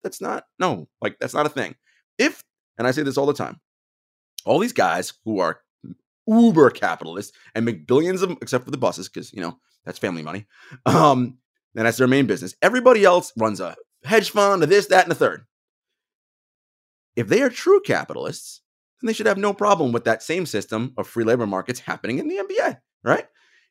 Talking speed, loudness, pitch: 200 wpm, -21 LUFS, 150 Hz